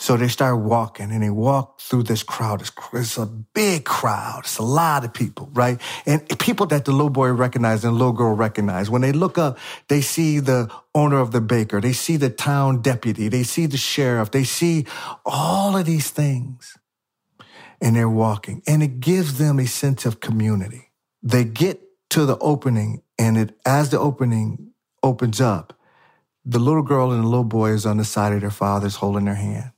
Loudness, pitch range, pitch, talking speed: -20 LUFS, 110-145 Hz, 125 Hz, 200 wpm